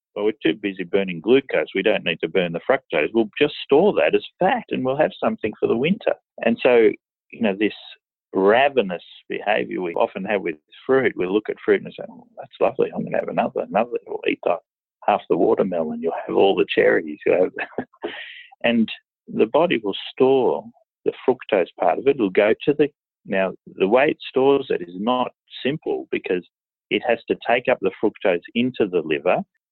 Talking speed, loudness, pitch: 200 wpm, -21 LUFS, 390 Hz